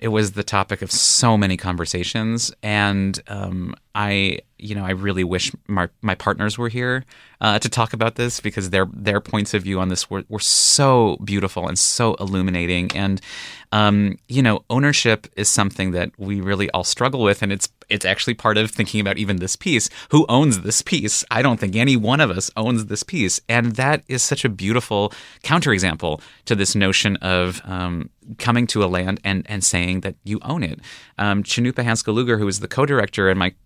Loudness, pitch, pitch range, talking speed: -19 LUFS, 105 Hz, 95-115 Hz, 200 wpm